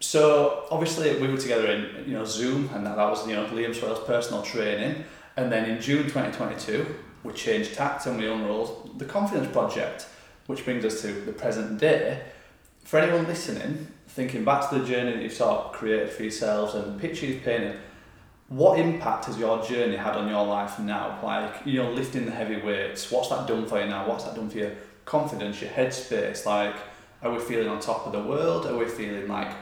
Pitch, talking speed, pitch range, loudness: 115 Hz, 205 wpm, 105-135 Hz, -27 LUFS